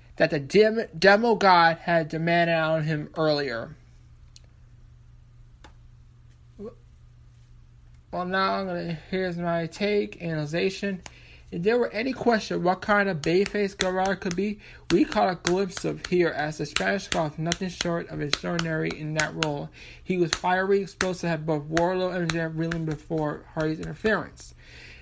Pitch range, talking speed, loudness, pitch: 150-190 Hz, 145 wpm, -25 LUFS, 170 Hz